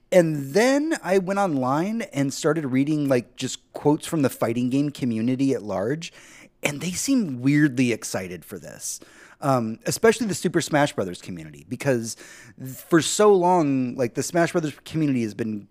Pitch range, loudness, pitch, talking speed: 125-170 Hz, -23 LUFS, 140 Hz, 165 wpm